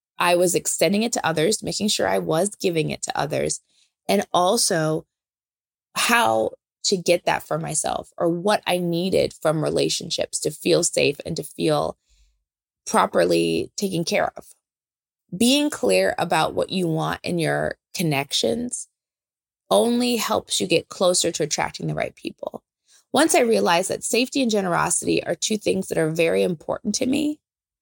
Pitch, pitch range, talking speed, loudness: 180 Hz, 165-220 Hz, 155 wpm, -22 LUFS